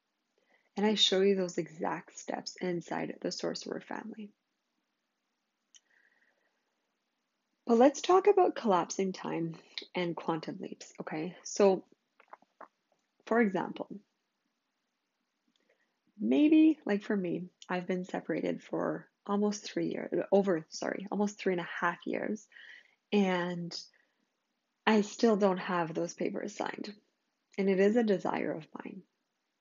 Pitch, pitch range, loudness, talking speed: 210 Hz, 180-260 Hz, -31 LUFS, 120 wpm